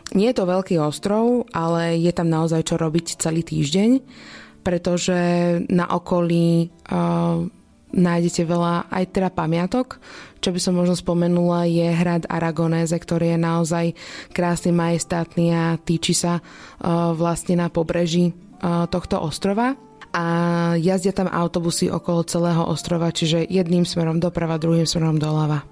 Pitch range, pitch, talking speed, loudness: 170-180 Hz, 170 Hz, 140 wpm, -21 LUFS